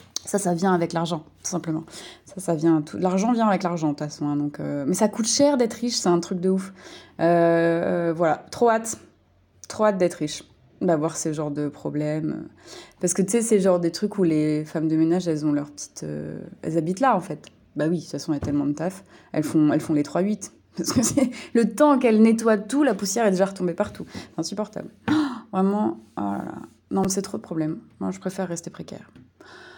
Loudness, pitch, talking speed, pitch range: -23 LUFS, 175 Hz, 235 wpm, 155-210 Hz